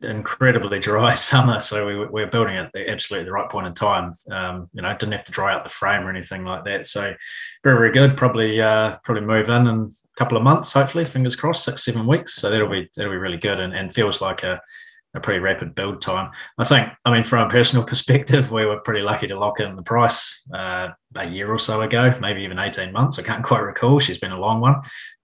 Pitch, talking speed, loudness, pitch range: 115 Hz, 240 wpm, -20 LUFS, 105-130 Hz